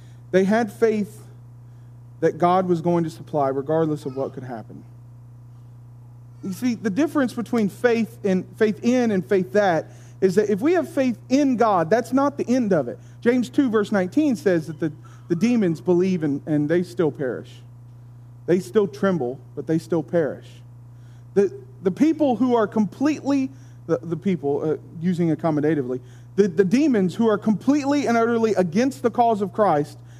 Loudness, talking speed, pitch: -22 LUFS, 175 wpm, 175 Hz